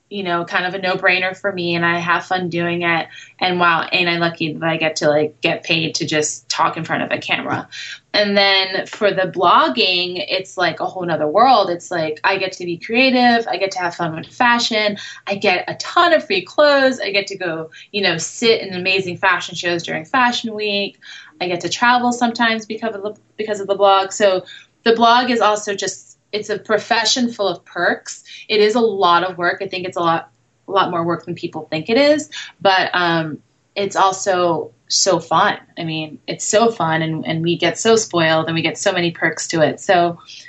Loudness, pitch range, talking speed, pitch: -17 LUFS, 170-210 Hz, 225 wpm, 185 Hz